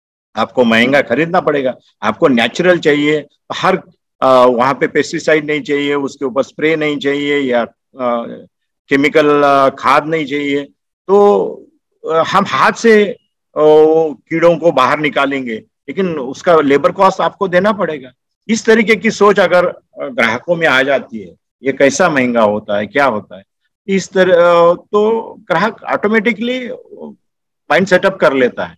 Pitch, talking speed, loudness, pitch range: 160 Hz, 140 wpm, -13 LUFS, 140-190 Hz